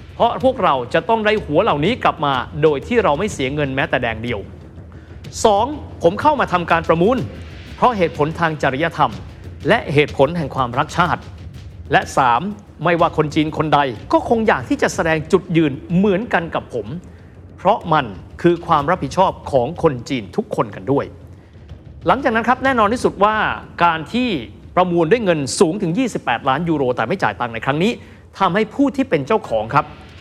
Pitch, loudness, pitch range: 170 Hz, -18 LUFS, 145-210 Hz